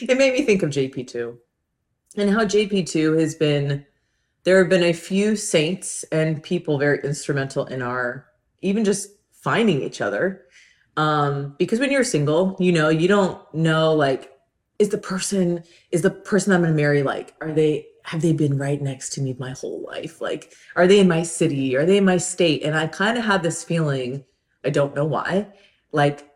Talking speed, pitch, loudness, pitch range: 195 wpm, 160 Hz, -21 LUFS, 140-190 Hz